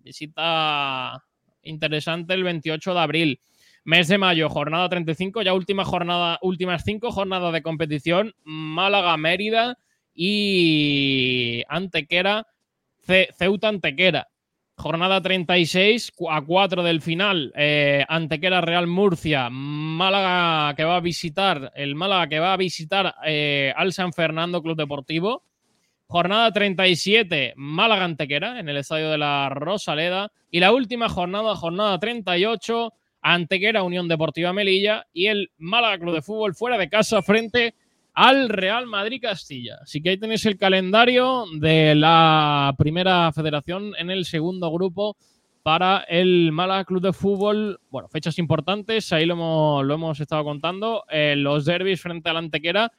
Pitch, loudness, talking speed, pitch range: 175 Hz, -21 LUFS, 135 wpm, 160-195 Hz